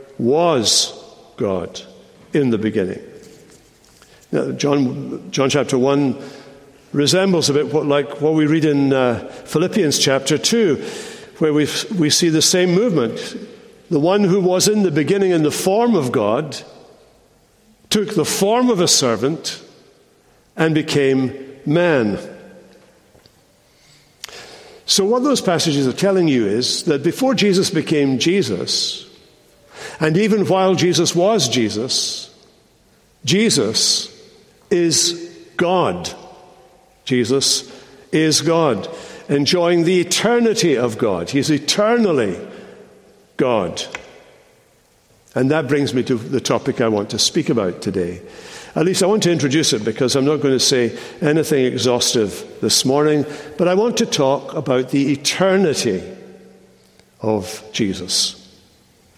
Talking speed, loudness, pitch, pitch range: 125 wpm, -17 LUFS, 155 Hz, 140-195 Hz